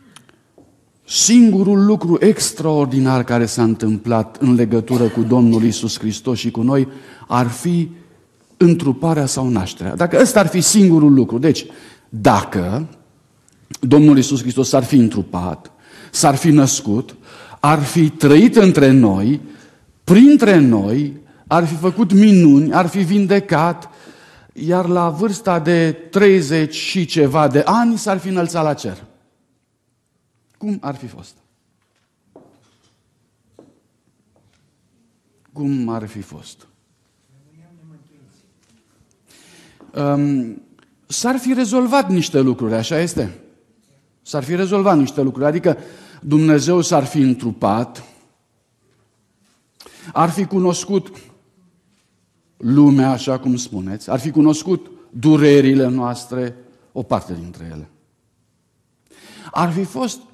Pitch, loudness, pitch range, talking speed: 145 Hz, -15 LUFS, 120-175 Hz, 110 wpm